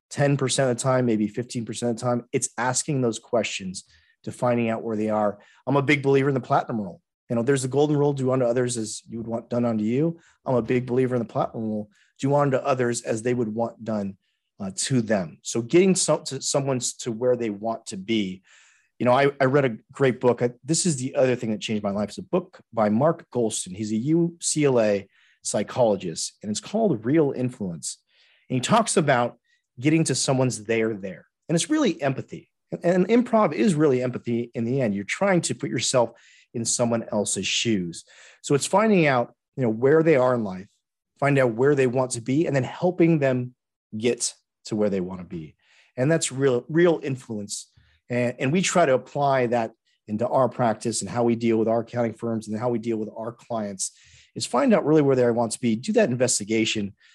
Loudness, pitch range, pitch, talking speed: -24 LUFS, 115-145 Hz, 125 Hz, 215 wpm